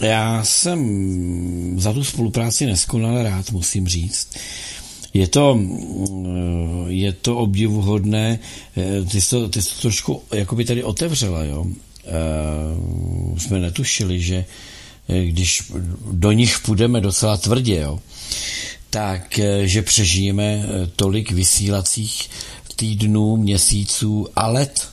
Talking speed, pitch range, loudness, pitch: 105 wpm, 90-110 Hz, -19 LUFS, 100 Hz